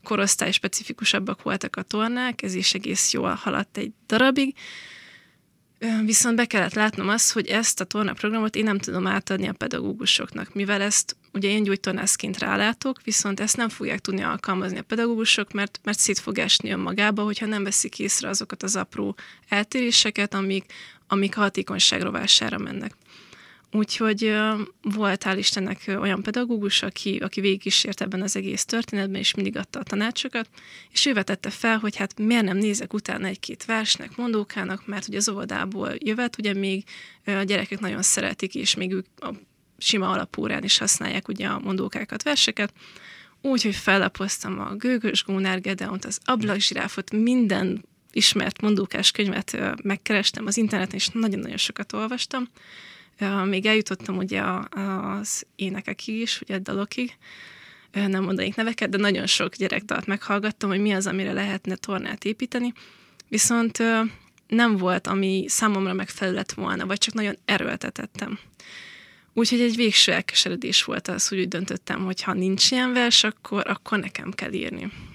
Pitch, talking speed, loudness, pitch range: 205 Hz, 150 wpm, -23 LUFS, 195-225 Hz